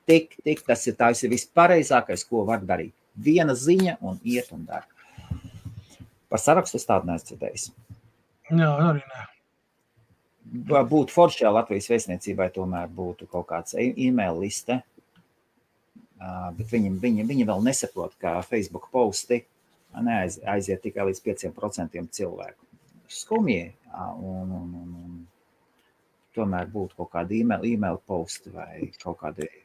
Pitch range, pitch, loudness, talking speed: 90-125 Hz, 105 Hz, -25 LUFS, 115 wpm